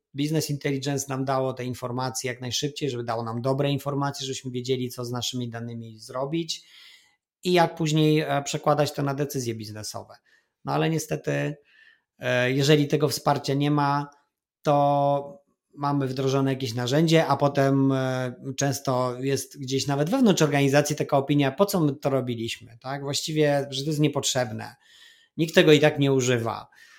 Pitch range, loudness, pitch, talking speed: 130-150 Hz, -25 LUFS, 140 Hz, 150 wpm